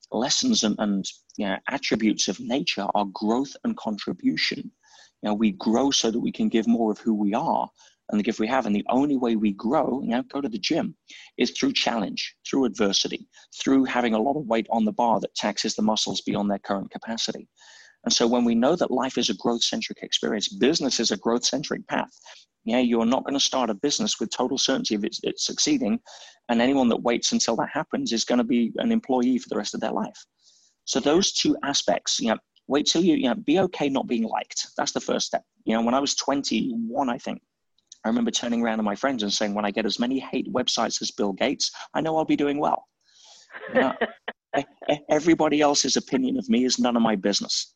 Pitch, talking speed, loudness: 125 Hz, 230 wpm, -24 LUFS